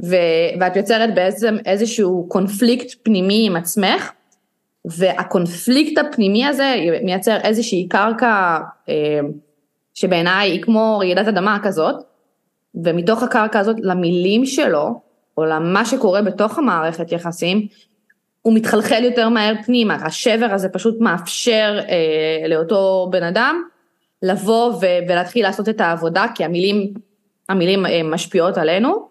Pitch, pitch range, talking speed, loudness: 200 Hz, 175-225 Hz, 110 wpm, -17 LUFS